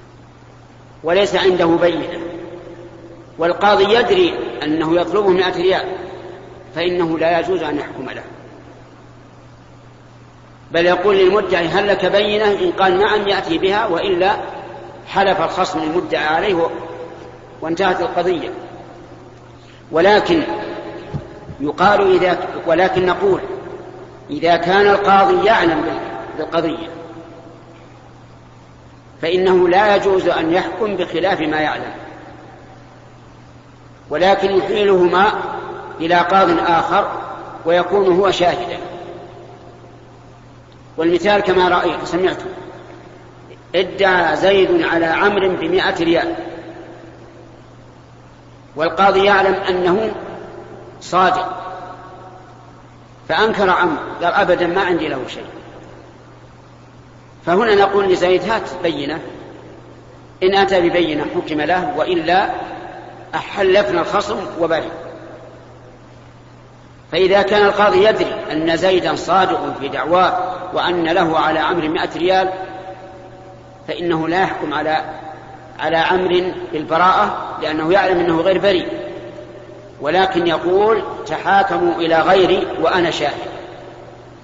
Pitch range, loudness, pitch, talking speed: 165-195 Hz, -16 LUFS, 180 Hz, 90 wpm